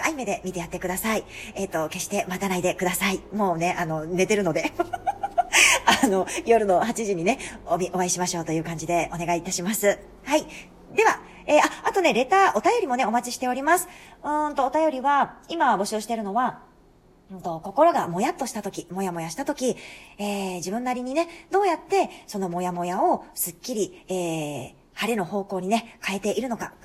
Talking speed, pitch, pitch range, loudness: 380 characters per minute, 205 Hz, 180-275 Hz, -24 LUFS